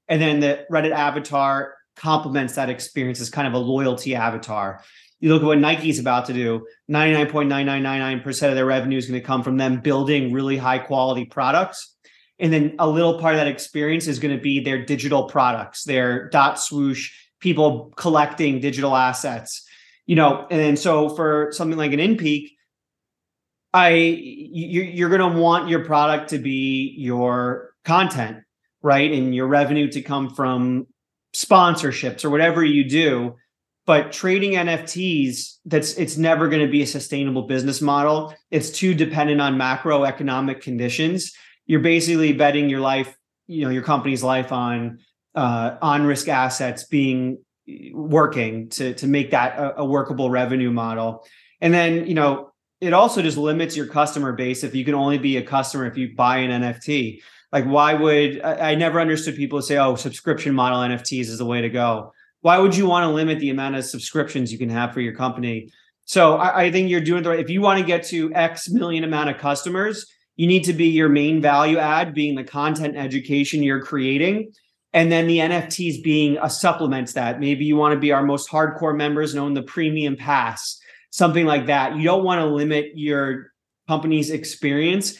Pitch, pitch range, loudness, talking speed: 145 Hz, 130-160 Hz, -20 LUFS, 190 wpm